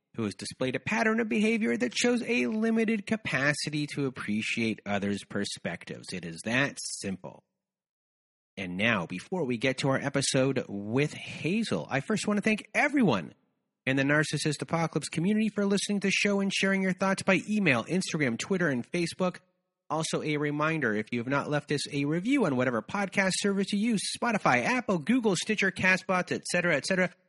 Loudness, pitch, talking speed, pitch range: -28 LUFS, 175 Hz, 180 wpm, 135-205 Hz